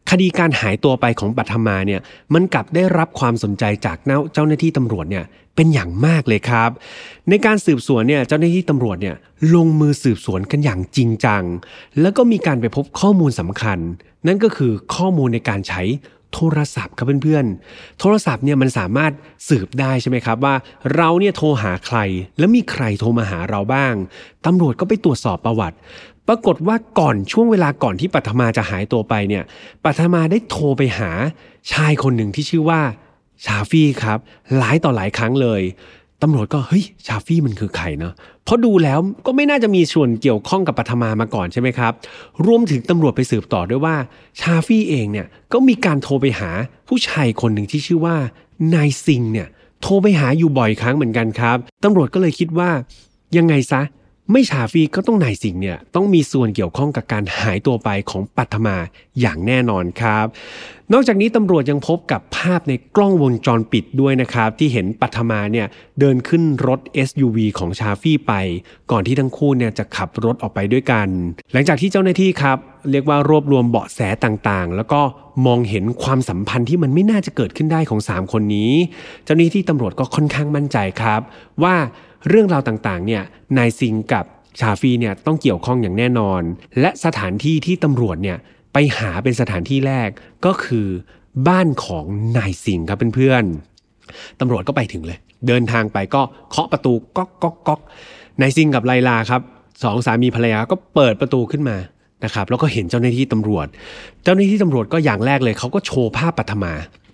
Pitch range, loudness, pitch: 110-155 Hz, -17 LUFS, 130 Hz